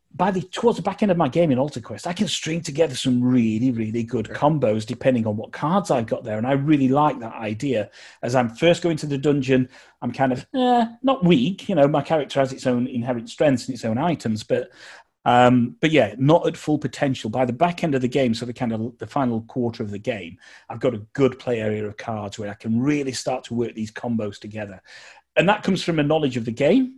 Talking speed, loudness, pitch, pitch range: 250 wpm, -22 LUFS, 130 Hz, 115-155 Hz